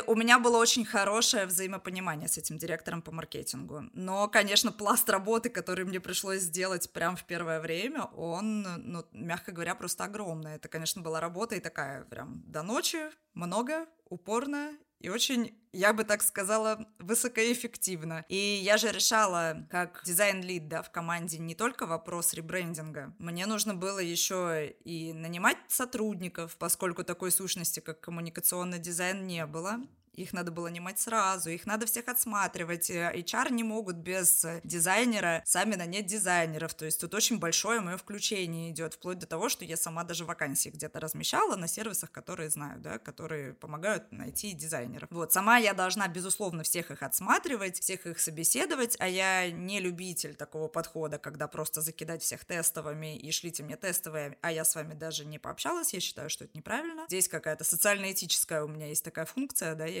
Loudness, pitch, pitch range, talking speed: -31 LUFS, 180 Hz, 165-205 Hz, 165 wpm